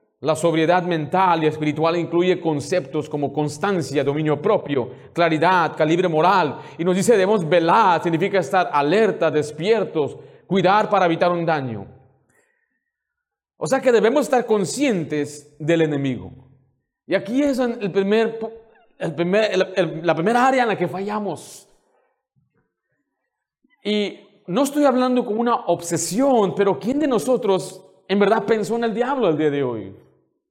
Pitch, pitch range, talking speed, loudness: 185 Hz, 155-220 Hz, 145 wpm, -20 LUFS